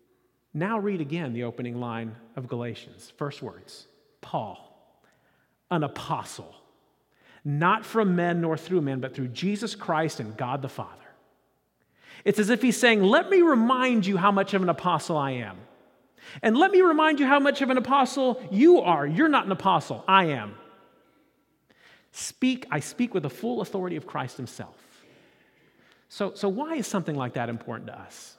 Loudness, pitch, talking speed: -25 LUFS, 180 Hz, 170 wpm